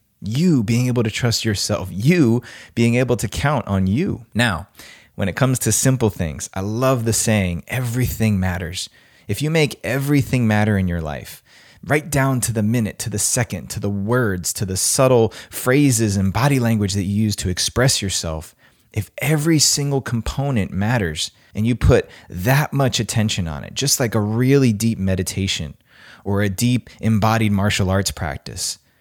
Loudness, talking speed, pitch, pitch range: -19 LUFS, 175 wpm, 110 Hz, 100-125 Hz